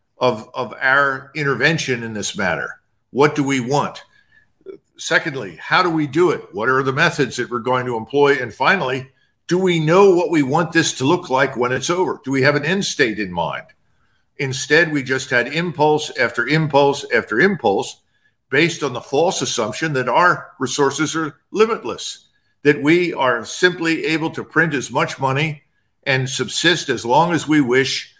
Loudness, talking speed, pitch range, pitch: -18 LUFS, 180 wpm, 130-165 Hz, 145 Hz